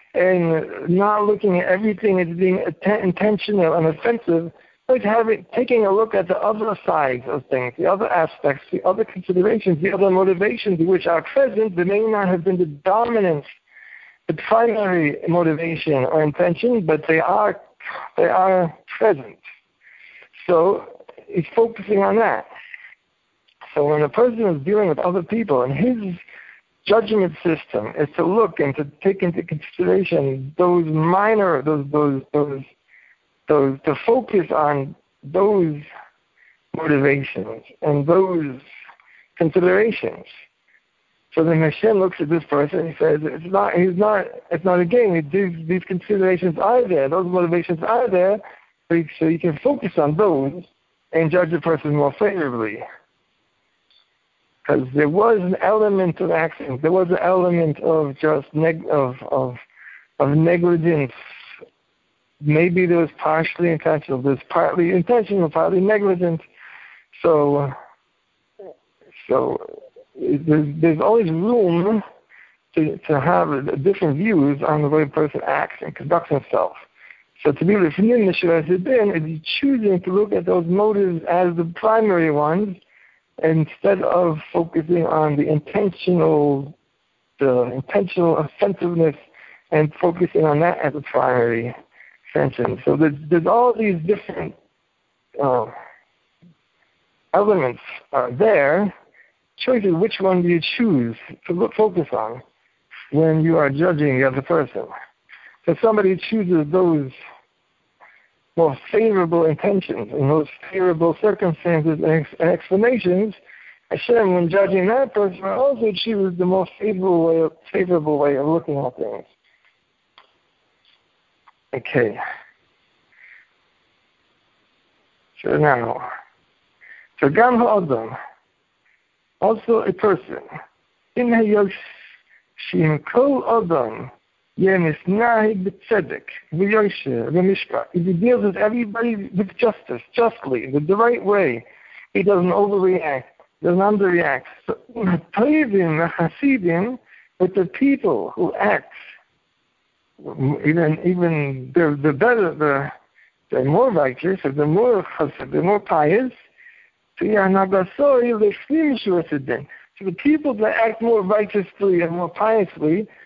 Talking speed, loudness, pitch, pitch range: 125 wpm, -19 LUFS, 180 Hz, 160-210 Hz